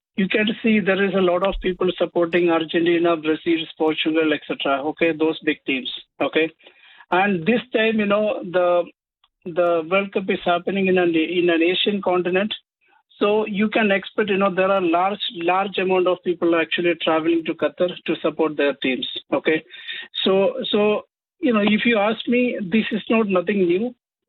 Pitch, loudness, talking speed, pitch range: 185 Hz, -20 LUFS, 175 wpm, 170-210 Hz